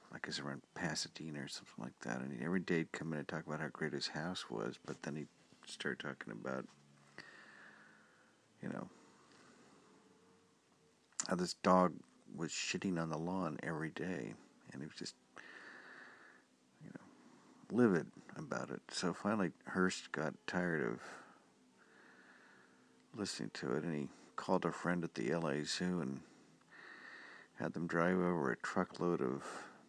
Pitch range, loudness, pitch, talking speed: 70-90 Hz, -40 LUFS, 80 Hz, 155 wpm